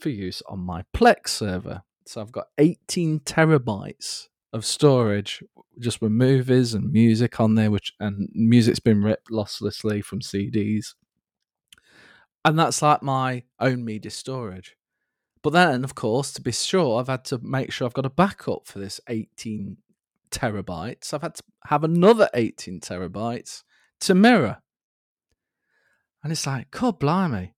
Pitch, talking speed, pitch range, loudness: 120 Hz, 150 wpm, 105-140 Hz, -23 LUFS